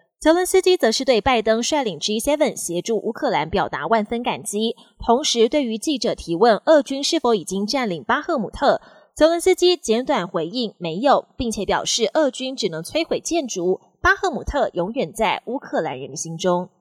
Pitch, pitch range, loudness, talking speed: 235 Hz, 205-295 Hz, -20 LUFS, 280 characters per minute